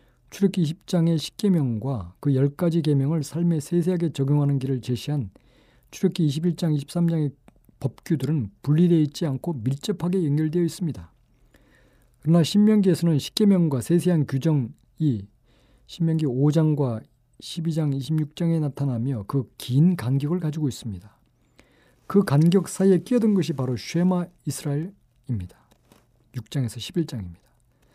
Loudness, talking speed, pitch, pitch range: -24 LUFS, 285 characters per minute, 150 Hz, 130-170 Hz